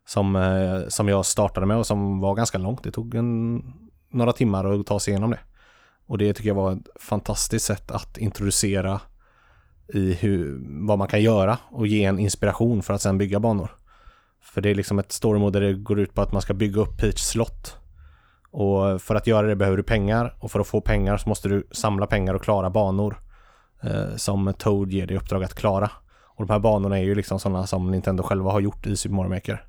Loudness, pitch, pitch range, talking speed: -23 LUFS, 100 Hz, 95-105 Hz, 220 wpm